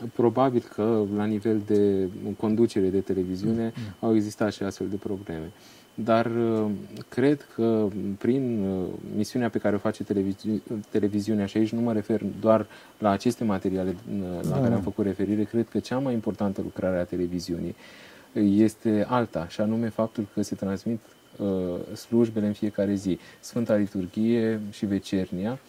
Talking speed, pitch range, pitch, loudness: 145 wpm, 100-115 Hz, 105 Hz, -27 LUFS